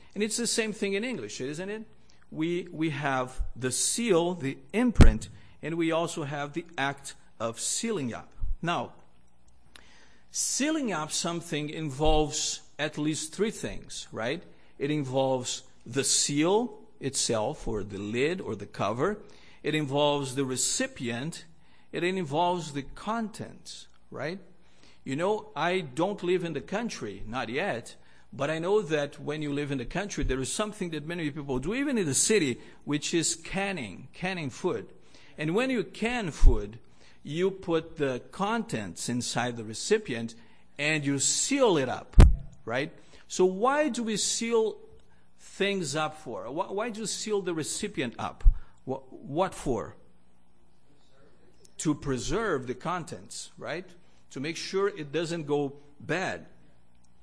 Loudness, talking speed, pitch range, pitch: -29 LUFS, 145 wpm, 130-190 Hz, 155 Hz